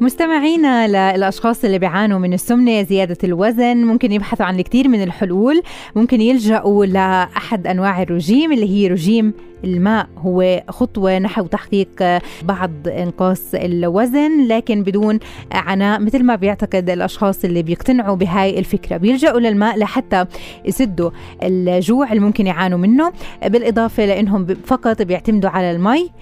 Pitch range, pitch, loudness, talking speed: 185-230 Hz, 205 Hz, -15 LUFS, 130 wpm